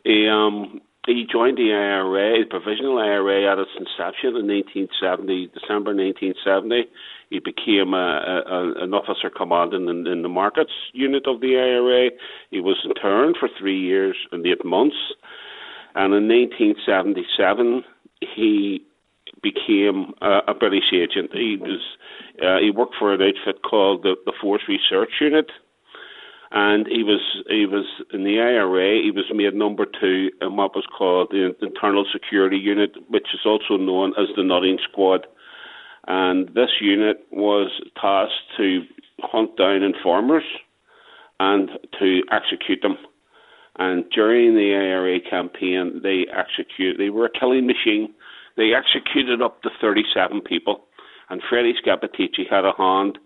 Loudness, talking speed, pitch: -20 LUFS, 145 wpm, 105 Hz